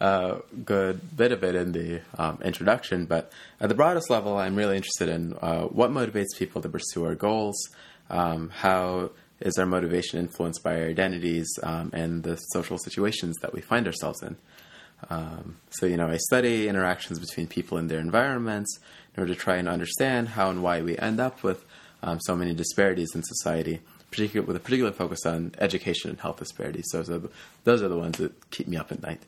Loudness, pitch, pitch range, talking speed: -27 LUFS, 90 Hz, 85-100 Hz, 200 wpm